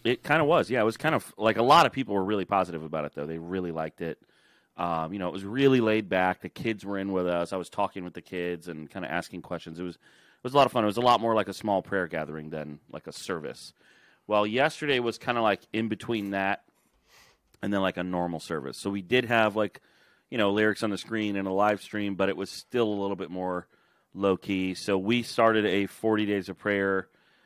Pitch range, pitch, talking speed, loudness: 90-105 Hz, 95 Hz, 260 wpm, -28 LUFS